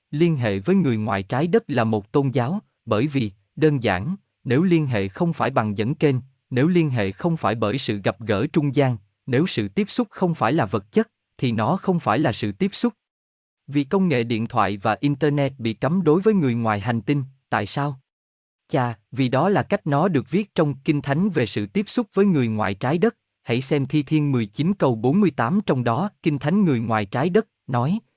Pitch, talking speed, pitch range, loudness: 140 Hz, 220 wpm, 115-170 Hz, -22 LUFS